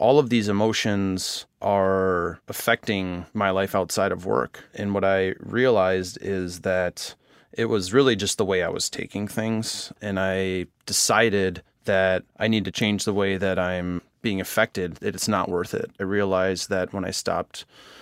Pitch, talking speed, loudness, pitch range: 95 Hz, 170 wpm, -24 LUFS, 95-100 Hz